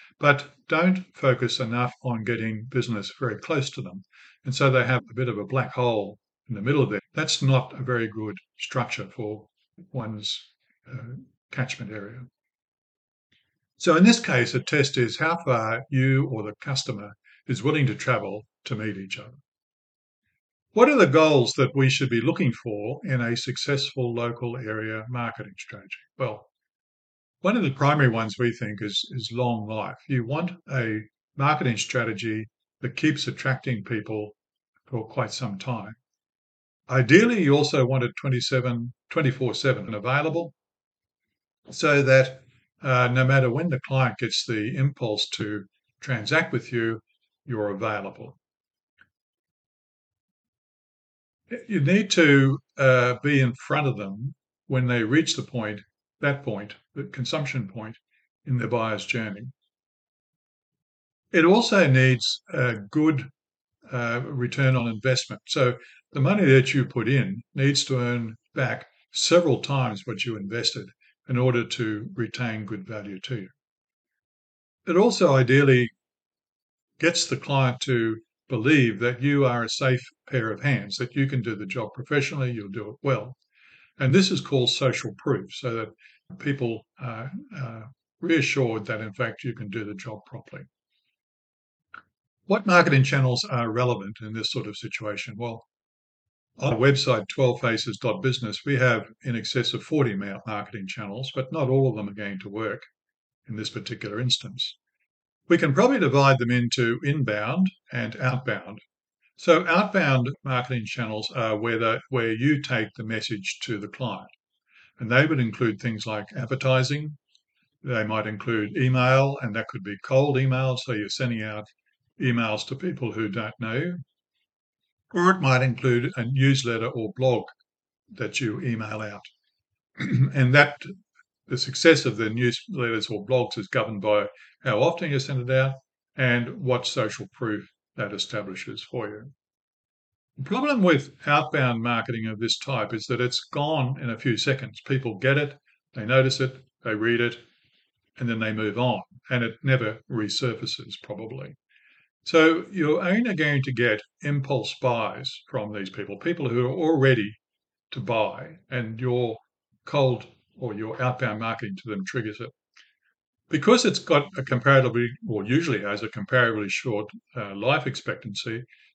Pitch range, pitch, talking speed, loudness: 110-135 Hz, 125 Hz, 155 wpm, -24 LUFS